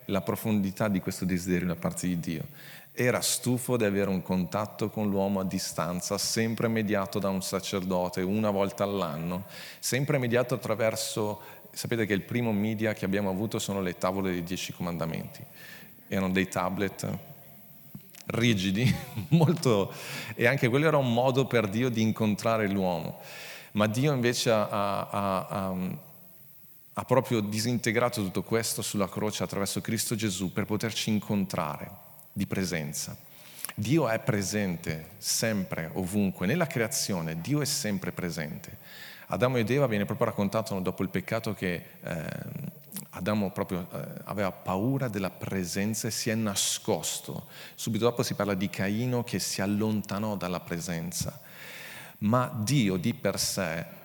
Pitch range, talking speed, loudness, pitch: 95-120 Hz, 145 wpm, -29 LUFS, 105 Hz